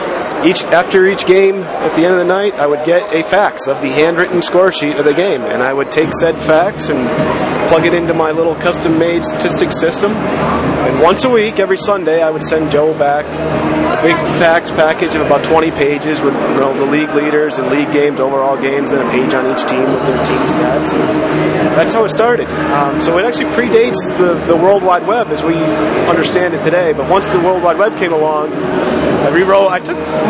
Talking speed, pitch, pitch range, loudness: 220 wpm, 160 Hz, 150-180 Hz, -12 LUFS